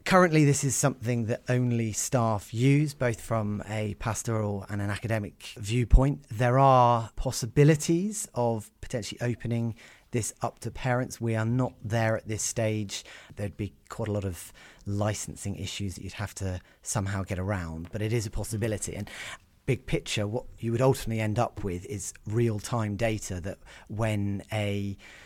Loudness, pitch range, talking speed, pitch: -29 LUFS, 100-120 Hz, 165 wpm, 110 Hz